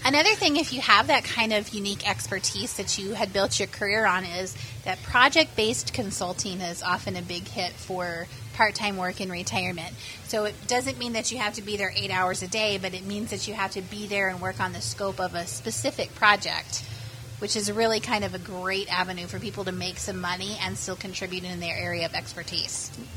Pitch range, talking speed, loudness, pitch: 175-210 Hz, 220 wpm, -26 LUFS, 190 Hz